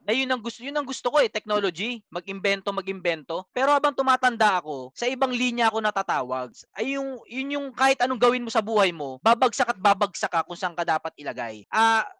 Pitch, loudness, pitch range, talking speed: 225 Hz, -24 LUFS, 190-255 Hz, 210 wpm